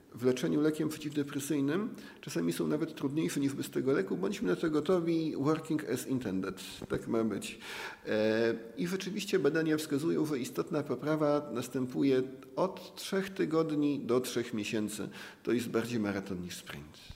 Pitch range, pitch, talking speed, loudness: 115-155 Hz, 140 Hz, 145 wpm, -33 LUFS